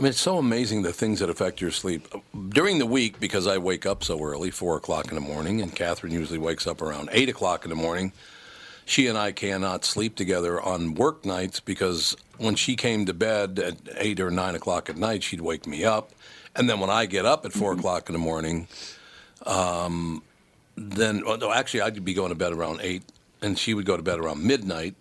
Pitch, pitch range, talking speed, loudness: 95 Hz, 85-110 Hz, 225 wpm, -26 LUFS